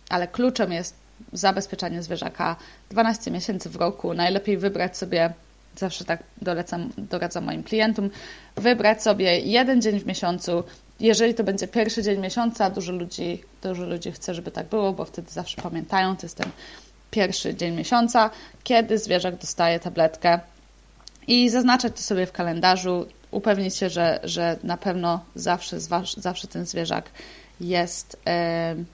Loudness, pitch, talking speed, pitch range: -24 LUFS, 185 Hz, 145 wpm, 175-215 Hz